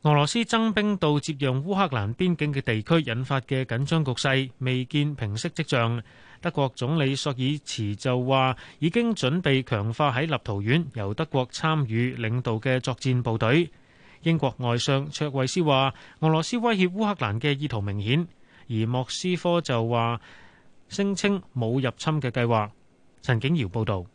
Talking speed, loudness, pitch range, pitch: 250 characters per minute, -25 LUFS, 120-160 Hz, 135 Hz